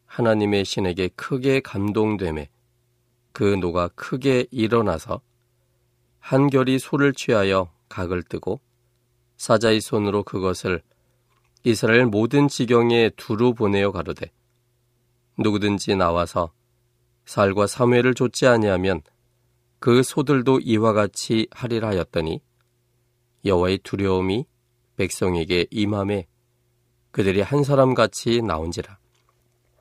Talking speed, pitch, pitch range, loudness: 240 characters per minute, 120 Hz, 100-120 Hz, -21 LUFS